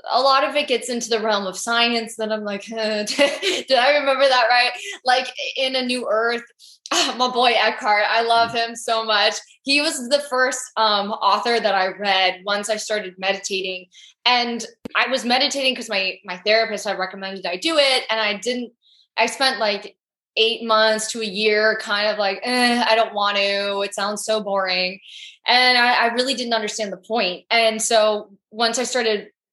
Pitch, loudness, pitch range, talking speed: 225 Hz, -19 LUFS, 205-245 Hz, 190 wpm